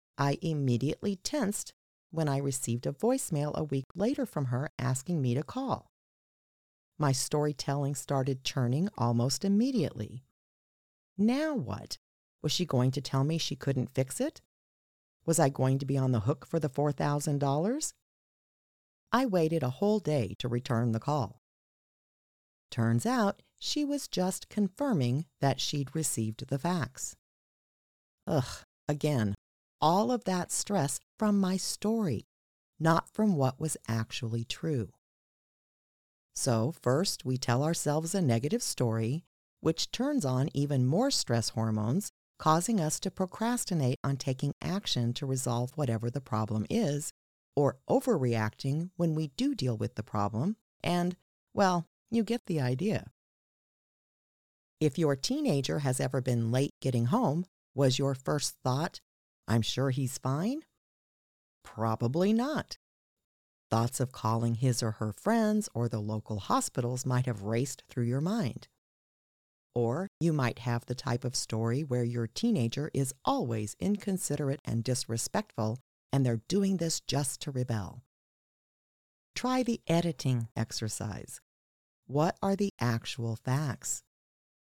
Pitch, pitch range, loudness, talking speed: 140 Hz, 120-170 Hz, -31 LUFS, 135 wpm